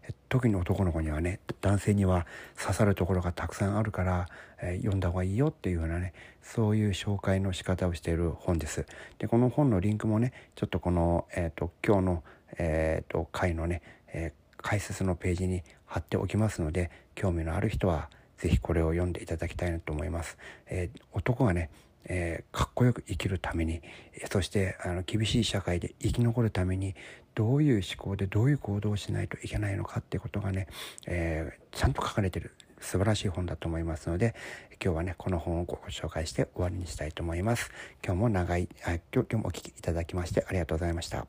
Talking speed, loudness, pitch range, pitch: 415 characters per minute, -31 LUFS, 85-105 Hz, 95 Hz